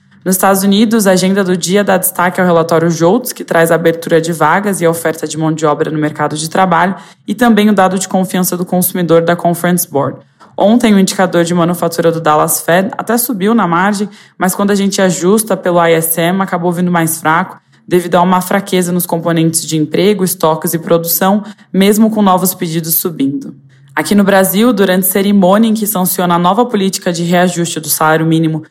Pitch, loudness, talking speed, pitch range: 180 Hz, -11 LUFS, 200 wpm, 165-195 Hz